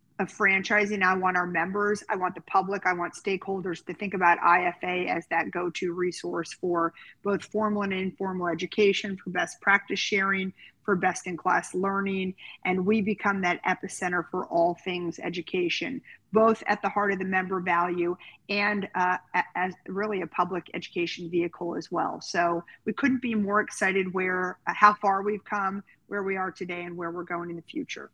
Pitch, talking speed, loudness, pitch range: 185 Hz, 185 wpm, -27 LUFS, 175-200 Hz